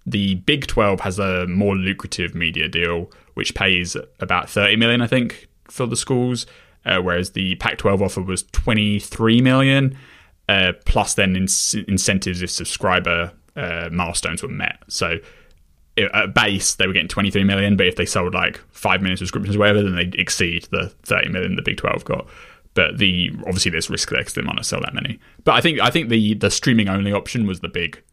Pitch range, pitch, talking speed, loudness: 90-105 Hz, 95 Hz, 195 wpm, -19 LUFS